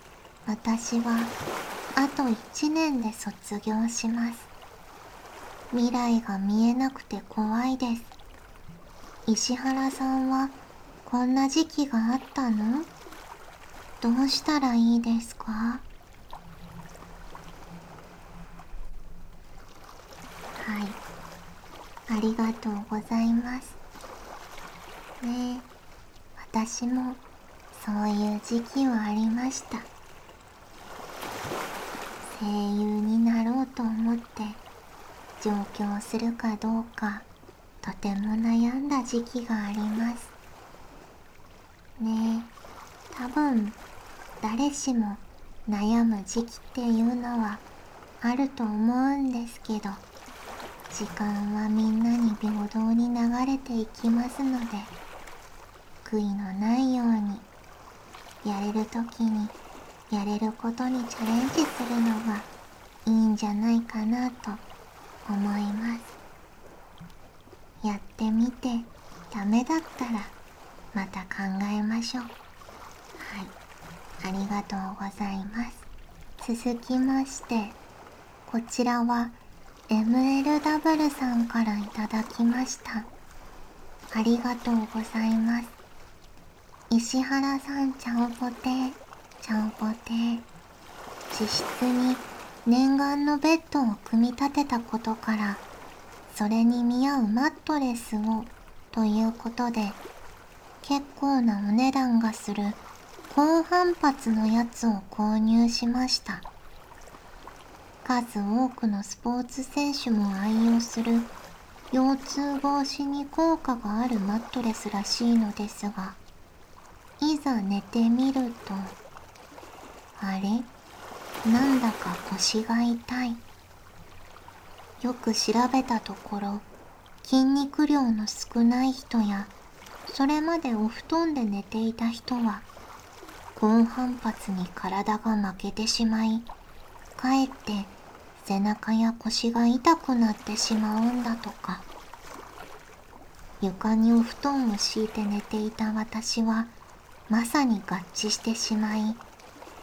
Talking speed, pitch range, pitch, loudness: 190 characters per minute, 215-250 Hz, 230 Hz, -27 LUFS